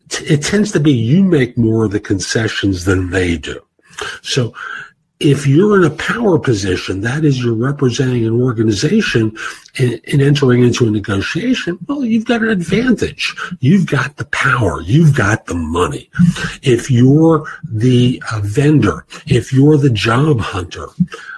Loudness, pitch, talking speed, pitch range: -14 LUFS, 130 Hz, 150 wpm, 110-160 Hz